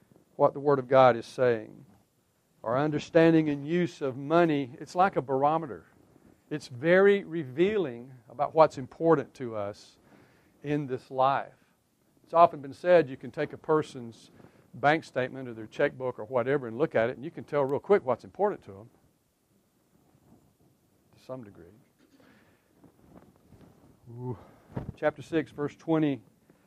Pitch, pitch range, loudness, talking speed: 145 Hz, 125-160 Hz, -27 LUFS, 150 wpm